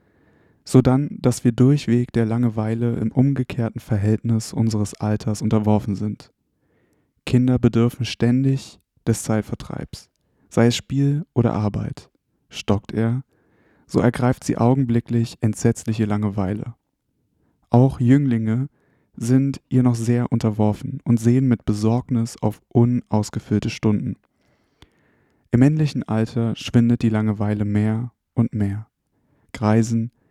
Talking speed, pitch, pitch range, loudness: 110 wpm, 115 Hz, 110-125 Hz, -21 LUFS